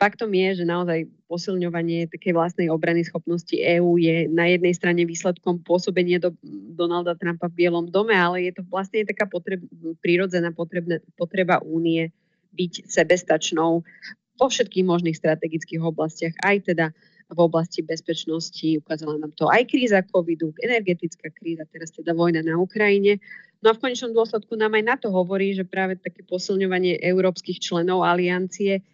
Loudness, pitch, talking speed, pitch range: -22 LUFS, 175 Hz, 150 wpm, 165-195 Hz